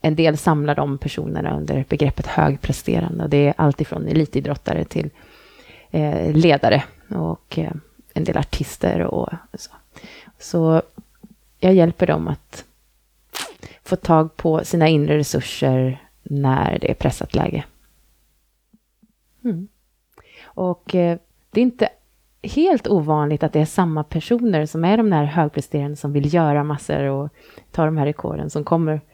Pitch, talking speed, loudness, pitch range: 155 Hz, 140 wpm, -20 LUFS, 145-180 Hz